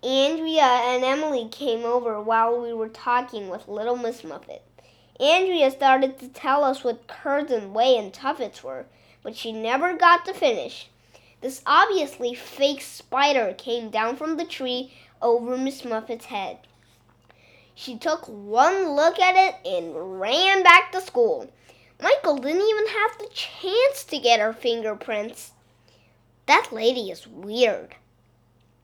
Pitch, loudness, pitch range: 255 Hz, -22 LUFS, 225-320 Hz